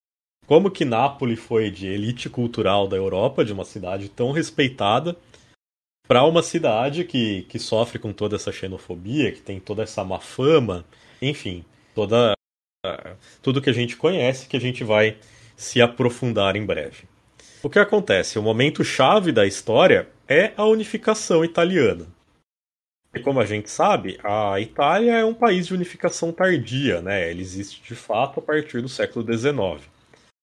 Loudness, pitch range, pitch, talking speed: -21 LUFS, 105-160 Hz, 120 Hz, 160 wpm